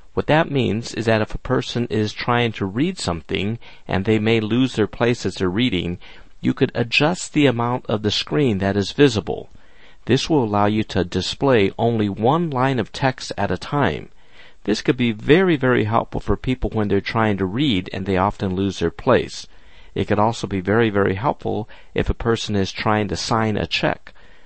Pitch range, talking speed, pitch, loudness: 100-125 Hz, 200 wpm, 110 Hz, -20 LUFS